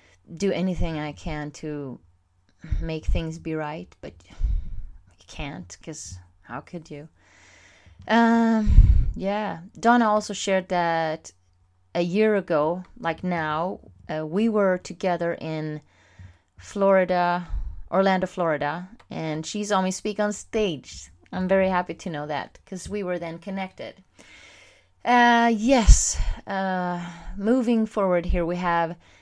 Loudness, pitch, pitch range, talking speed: -24 LUFS, 175 Hz, 150-195 Hz, 125 wpm